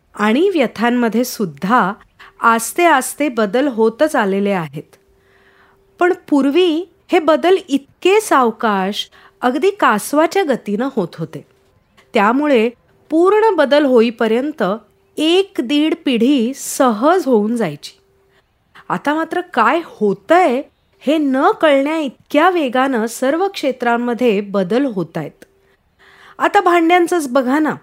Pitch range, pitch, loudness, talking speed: 225-320 Hz, 265 Hz, -15 LUFS, 105 wpm